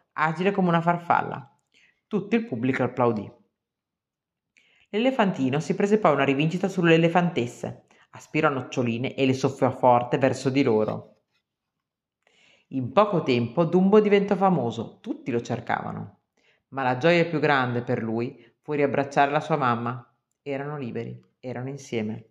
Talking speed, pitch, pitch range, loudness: 135 wpm, 140 Hz, 120-170 Hz, -24 LUFS